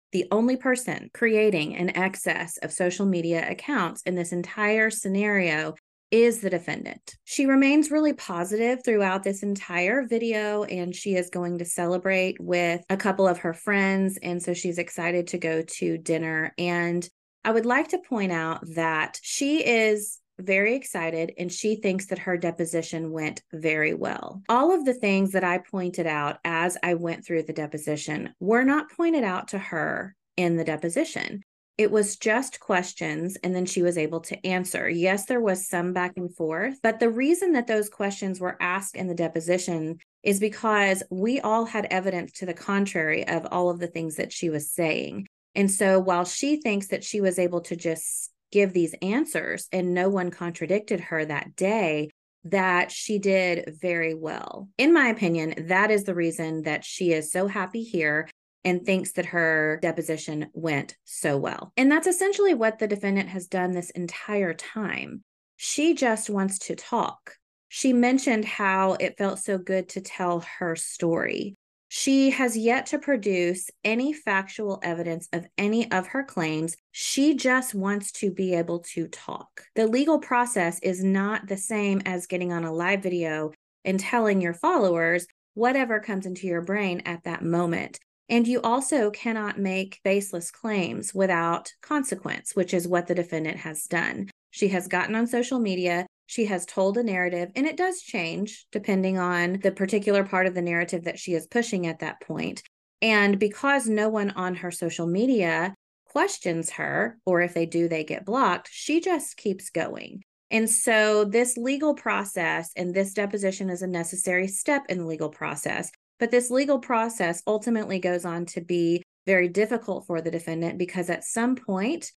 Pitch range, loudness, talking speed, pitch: 175-215 Hz, -25 LUFS, 175 wpm, 190 Hz